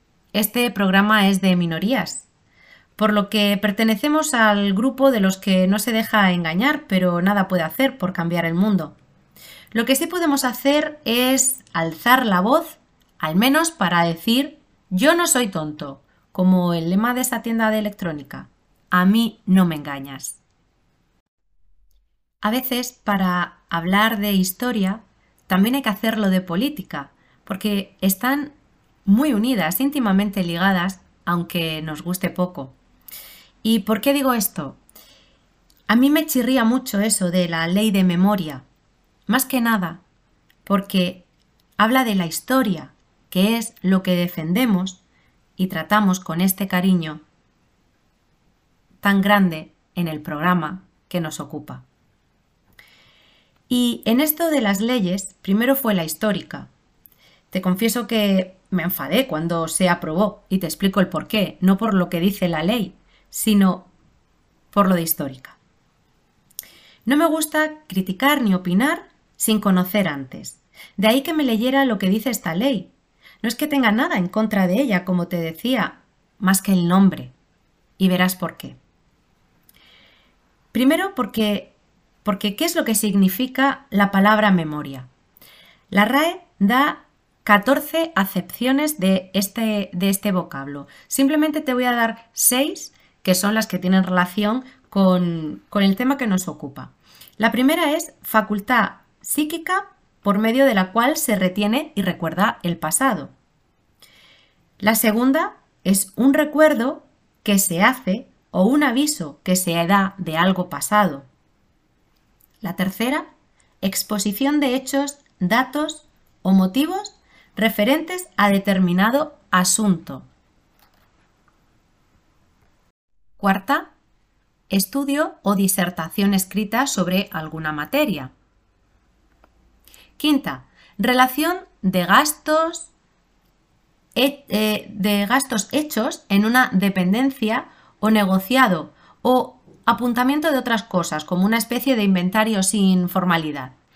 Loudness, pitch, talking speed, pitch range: -20 LUFS, 205 Hz, 130 wpm, 180-255 Hz